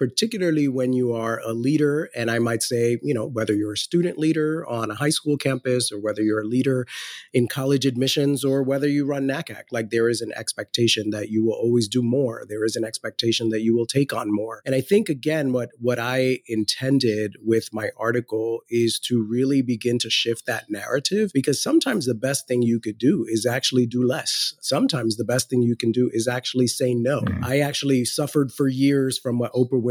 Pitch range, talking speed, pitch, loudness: 115-135 Hz, 215 wpm, 125 Hz, -22 LUFS